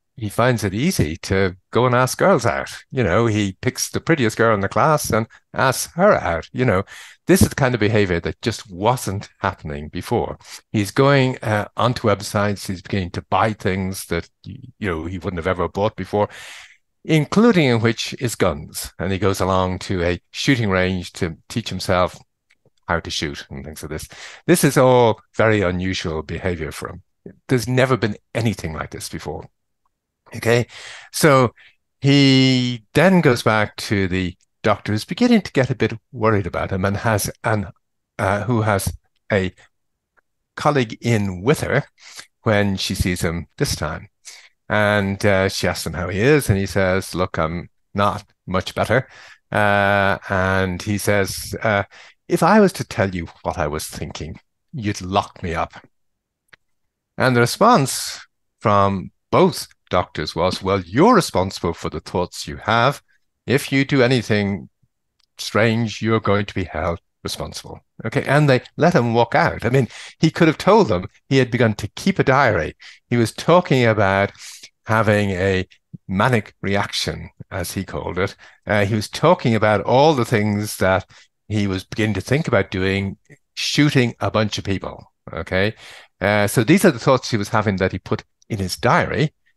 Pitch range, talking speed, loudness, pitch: 95-120 Hz, 175 wpm, -19 LUFS, 105 Hz